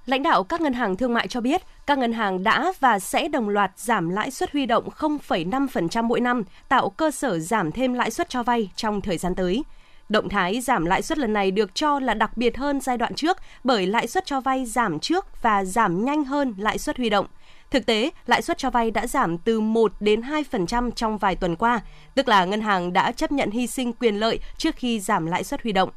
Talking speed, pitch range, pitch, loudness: 240 wpm, 210-275 Hz, 235 Hz, -23 LUFS